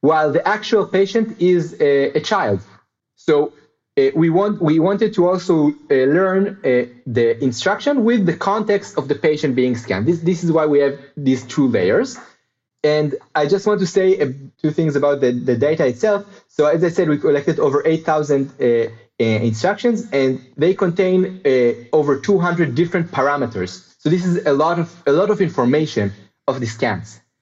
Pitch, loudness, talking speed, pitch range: 155 Hz, -18 LUFS, 185 wpm, 130-190 Hz